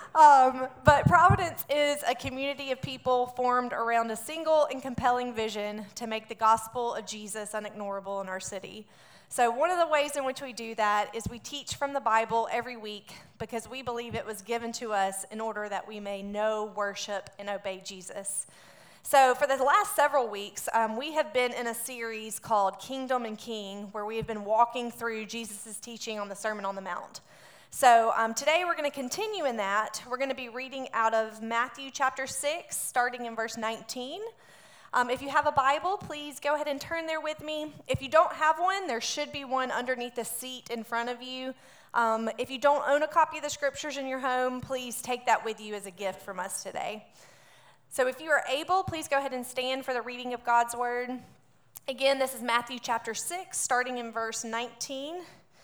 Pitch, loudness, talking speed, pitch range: 245 Hz, -29 LUFS, 210 wpm, 220-275 Hz